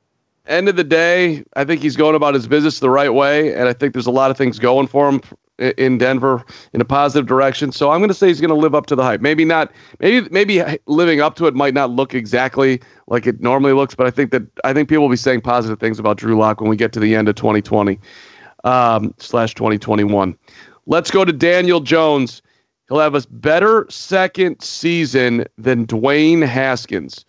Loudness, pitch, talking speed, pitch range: -15 LUFS, 135 Hz, 220 wpm, 120-155 Hz